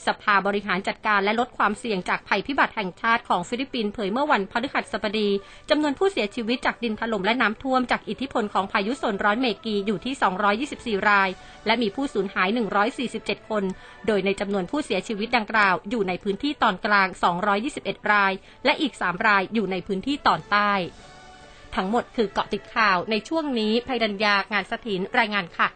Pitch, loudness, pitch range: 215 Hz, -24 LUFS, 200-240 Hz